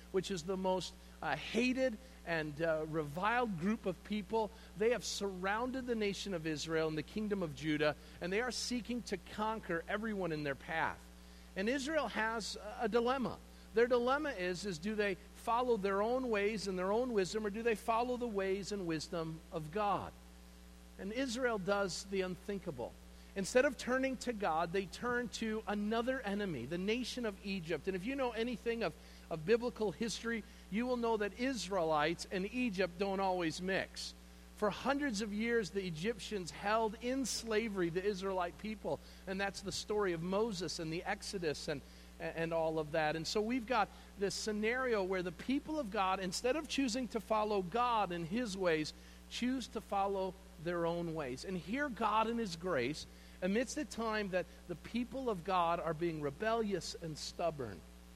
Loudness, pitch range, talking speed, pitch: -38 LUFS, 170-230 Hz, 175 wpm, 200 Hz